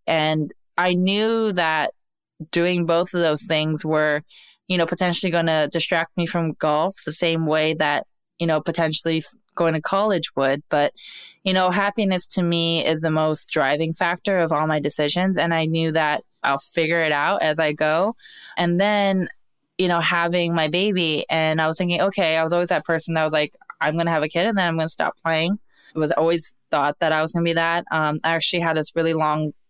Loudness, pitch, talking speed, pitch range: -21 LUFS, 165 Hz, 215 wpm, 155-175 Hz